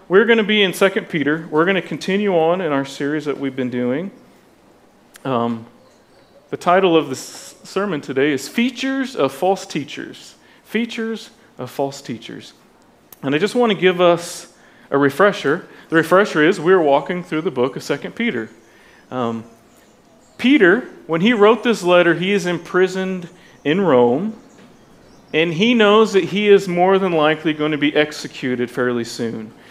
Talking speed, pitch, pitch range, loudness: 165 wpm, 170 Hz, 140-200 Hz, -17 LUFS